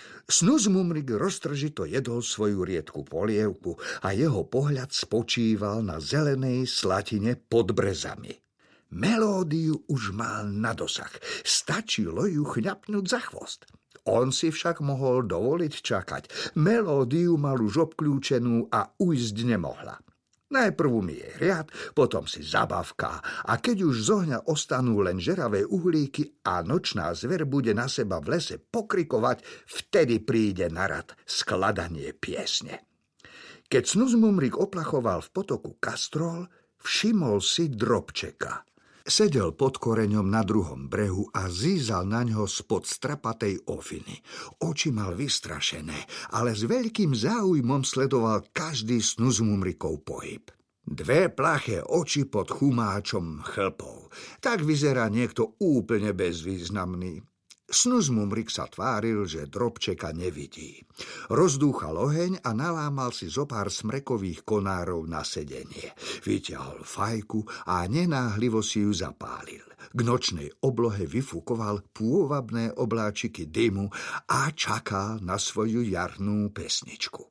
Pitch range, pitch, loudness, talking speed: 105-150 Hz, 120 Hz, -27 LUFS, 120 wpm